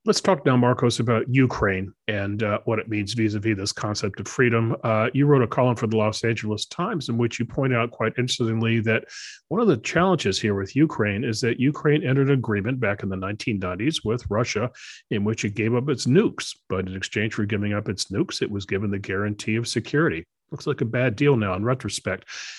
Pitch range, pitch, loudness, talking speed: 105-125 Hz, 115 Hz, -23 LUFS, 225 wpm